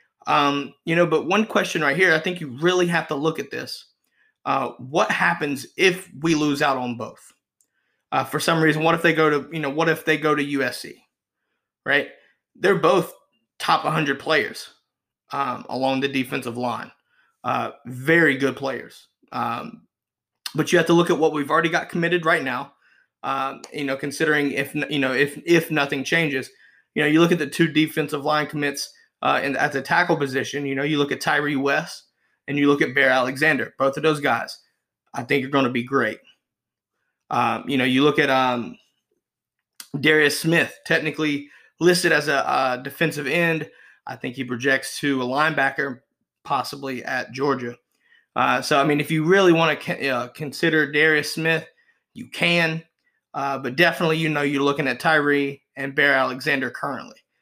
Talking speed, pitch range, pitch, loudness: 185 wpm, 140-160 Hz, 150 Hz, -21 LUFS